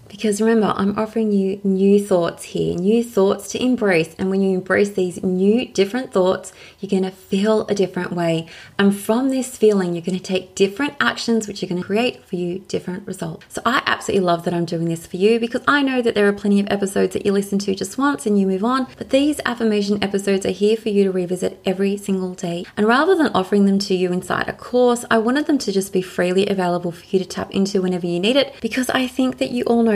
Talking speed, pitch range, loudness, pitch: 245 wpm, 185-225 Hz, -19 LUFS, 200 Hz